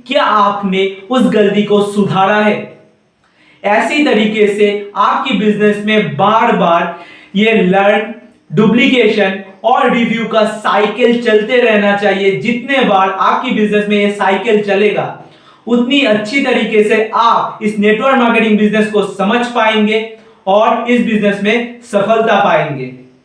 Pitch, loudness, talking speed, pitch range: 215 Hz, -11 LUFS, 130 wpm, 205-230 Hz